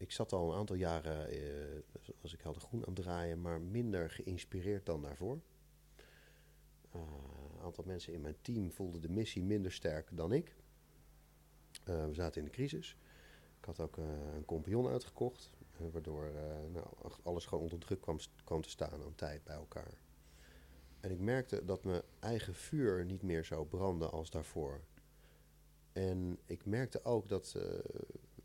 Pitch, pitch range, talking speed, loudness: 85 Hz, 75-95 Hz, 175 wpm, -42 LUFS